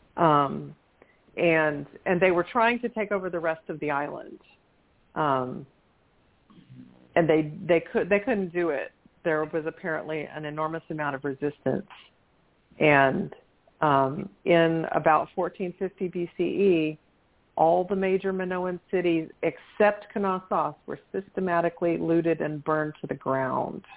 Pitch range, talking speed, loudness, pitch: 155-185 Hz, 130 wpm, -26 LUFS, 165 Hz